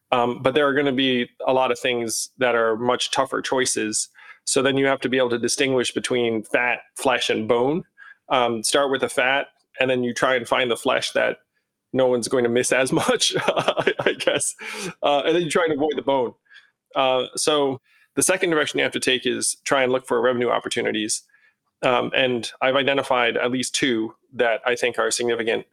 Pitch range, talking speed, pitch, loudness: 120-135 Hz, 210 wpm, 125 Hz, -21 LUFS